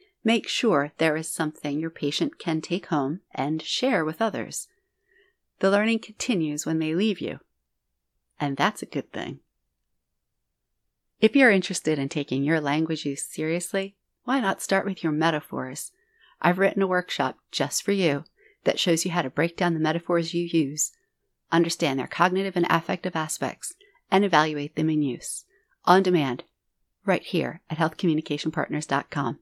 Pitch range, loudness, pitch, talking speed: 155-195 Hz, -25 LUFS, 165 Hz, 155 wpm